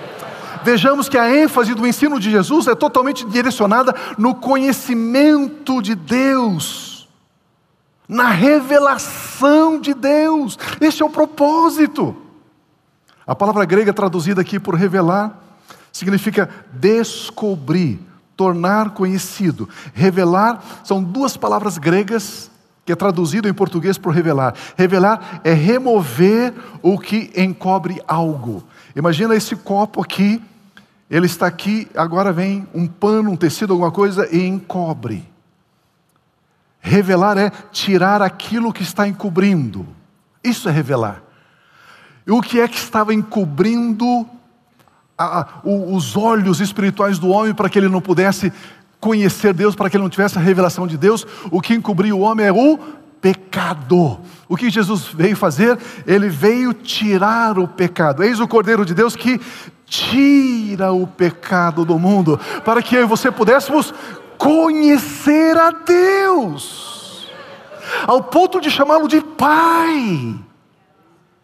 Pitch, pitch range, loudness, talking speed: 205 Hz, 185-240 Hz, -16 LUFS, 130 wpm